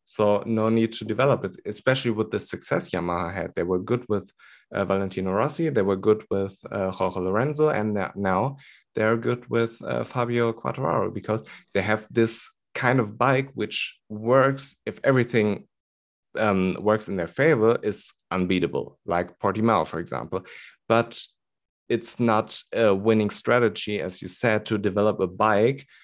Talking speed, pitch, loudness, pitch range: 160 wpm, 110 Hz, -25 LUFS, 95-115 Hz